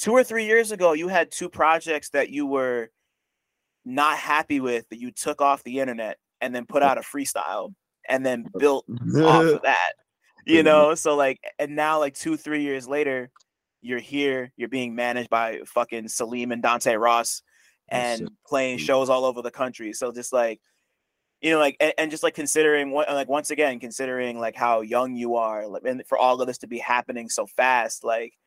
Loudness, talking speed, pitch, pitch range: -23 LUFS, 200 wpm, 135 Hz, 120-150 Hz